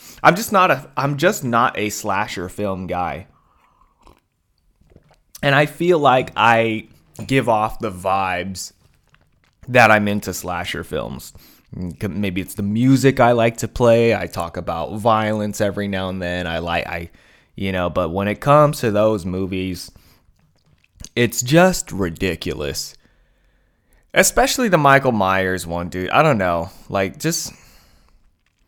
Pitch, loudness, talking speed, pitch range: 105 Hz, -18 LUFS, 140 wpm, 90-120 Hz